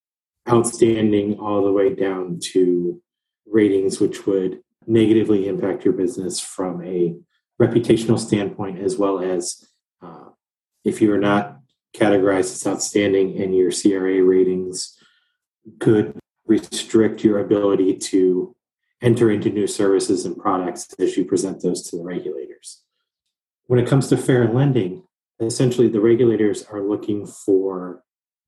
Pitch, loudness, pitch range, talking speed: 105 Hz, -19 LUFS, 95-120 Hz, 130 wpm